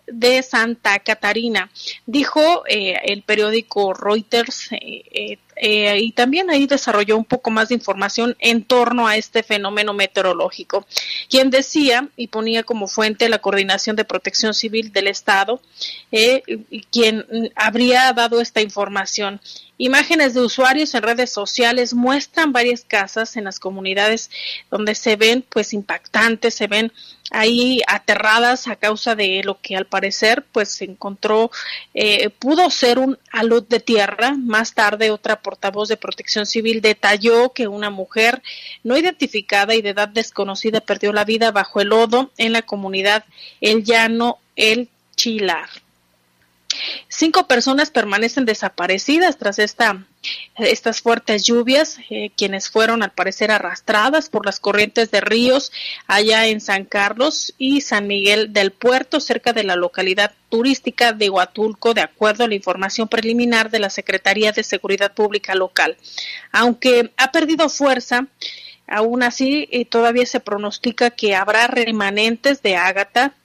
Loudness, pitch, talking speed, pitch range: -17 LUFS, 225 Hz, 145 wpm, 205-245 Hz